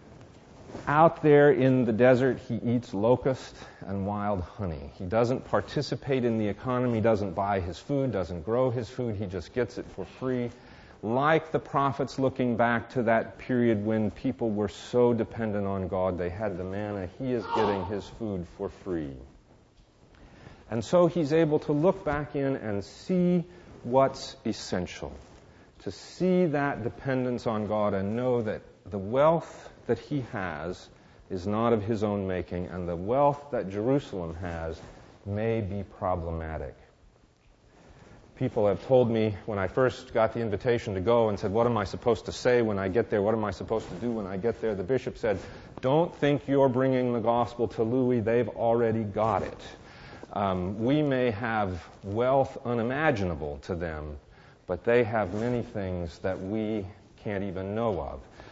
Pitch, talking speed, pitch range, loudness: 115 Hz, 170 wpm, 100-125 Hz, -28 LUFS